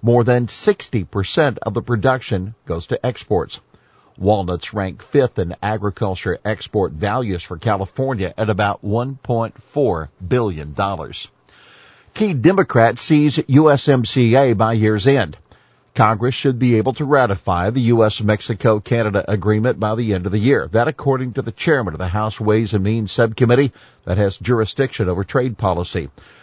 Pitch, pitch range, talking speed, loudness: 110 Hz, 100-125 Hz, 145 wpm, -18 LUFS